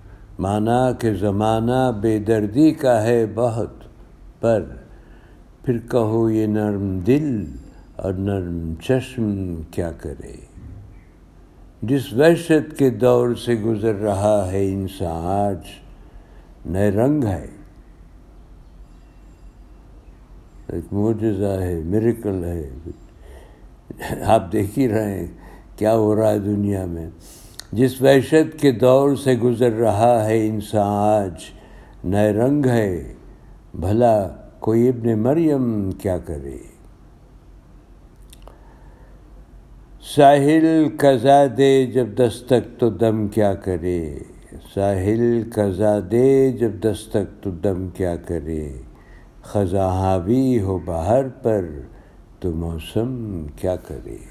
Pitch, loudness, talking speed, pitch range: 105 Hz, -19 LUFS, 105 wpm, 90-120 Hz